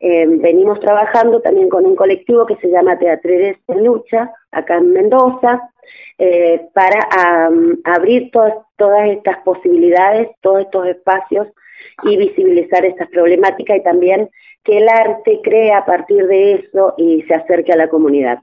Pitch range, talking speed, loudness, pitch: 175-225 Hz, 155 wpm, -12 LUFS, 195 Hz